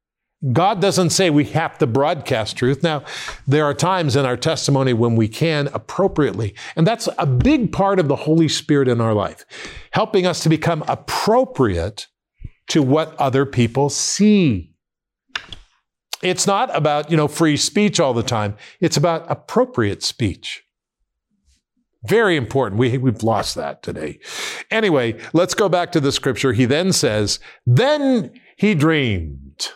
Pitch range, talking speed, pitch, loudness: 130-175 Hz, 150 wpm, 150 Hz, -18 LUFS